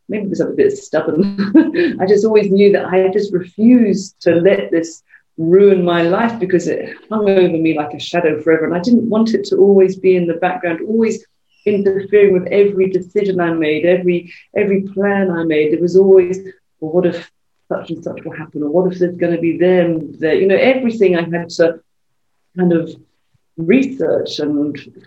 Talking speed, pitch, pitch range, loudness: 195 wpm, 185 Hz, 170-200 Hz, -14 LUFS